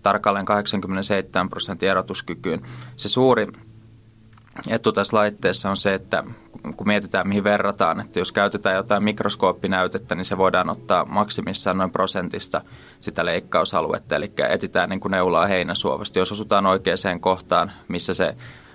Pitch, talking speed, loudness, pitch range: 100 Hz, 135 wpm, -20 LUFS, 95-110 Hz